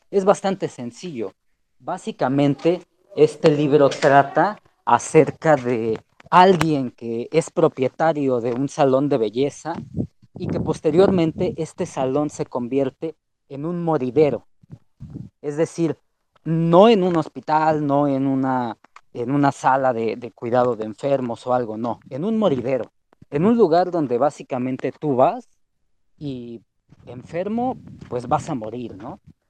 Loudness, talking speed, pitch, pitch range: -20 LUFS, 130 wpm, 145 Hz, 125-165 Hz